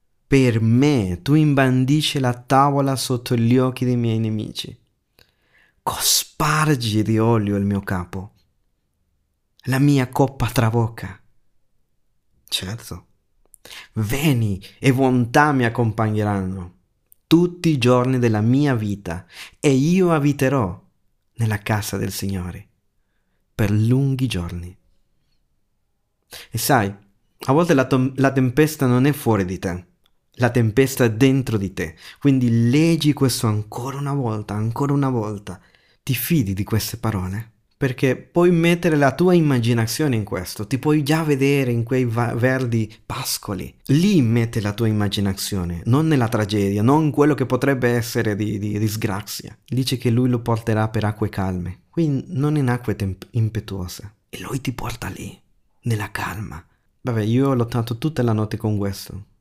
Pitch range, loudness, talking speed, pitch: 105-135 Hz, -20 LUFS, 140 wpm, 115 Hz